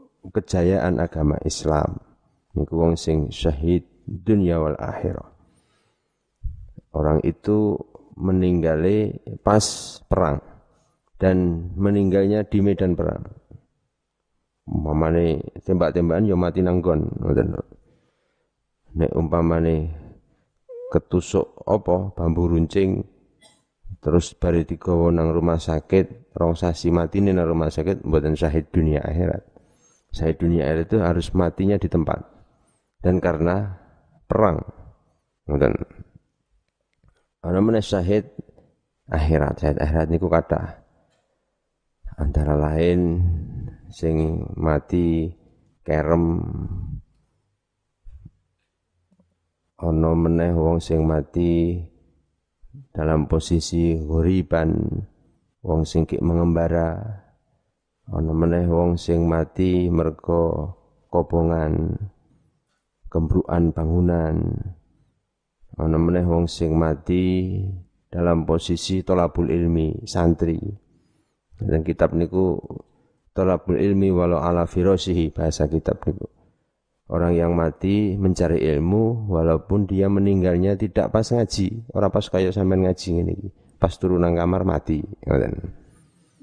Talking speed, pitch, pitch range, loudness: 90 wpm, 85 Hz, 80-95 Hz, -22 LUFS